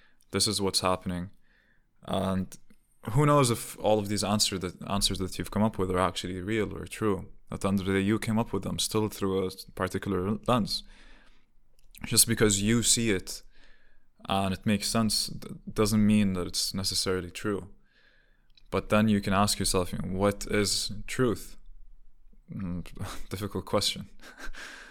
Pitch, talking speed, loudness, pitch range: 100 Hz, 165 wpm, -28 LUFS, 95-105 Hz